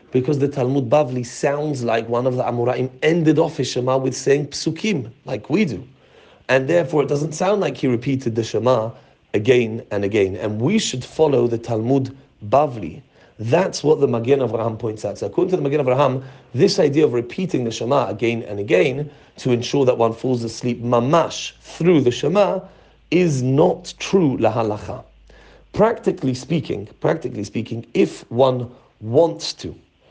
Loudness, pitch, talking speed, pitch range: -20 LUFS, 130 Hz, 165 wpm, 120-150 Hz